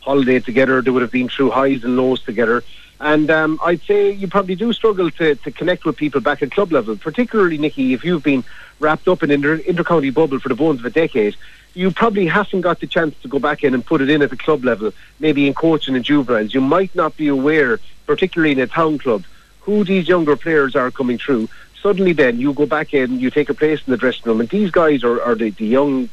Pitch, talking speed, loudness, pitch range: 150 Hz, 250 wpm, -17 LUFS, 130-170 Hz